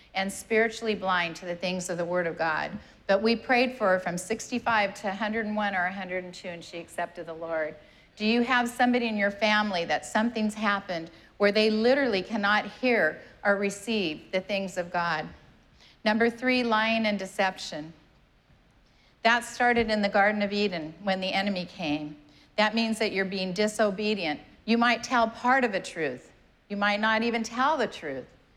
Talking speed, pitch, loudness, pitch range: 175 wpm, 205 Hz, -27 LUFS, 180-225 Hz